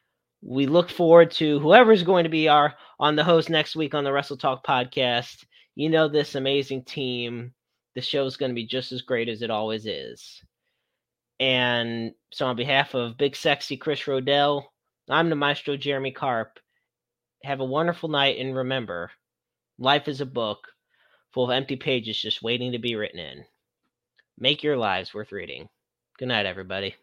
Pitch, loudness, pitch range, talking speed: 135 Hz, -23 LUFS, 120-150 Hz, 175 wpm